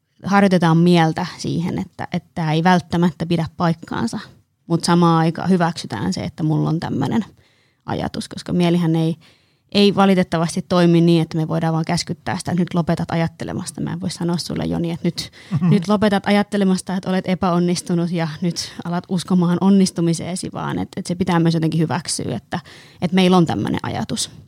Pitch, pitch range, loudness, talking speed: 175 Hz, 165-185 Hz, -19 LUFS, 170 wpm